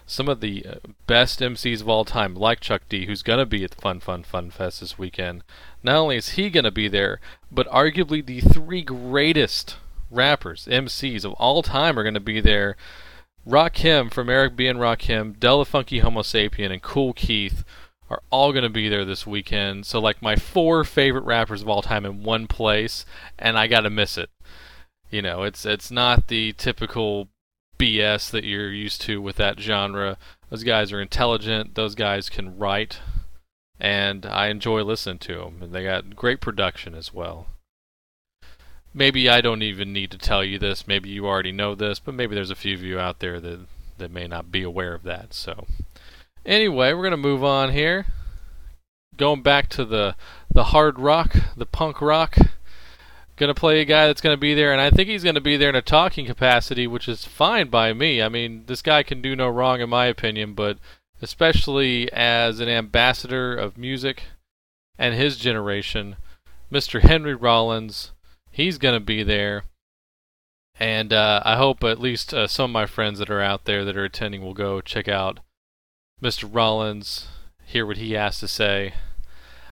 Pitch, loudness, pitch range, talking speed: 105 Hz, -21 LUFS, 95-125 Hz, 195 wpm